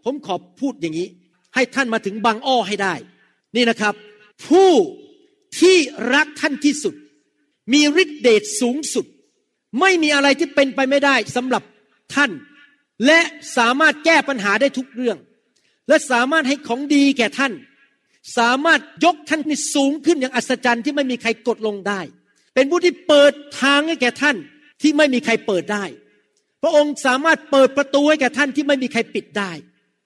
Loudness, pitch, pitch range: -17 LUFS, 275 Hz, 235-300 Hz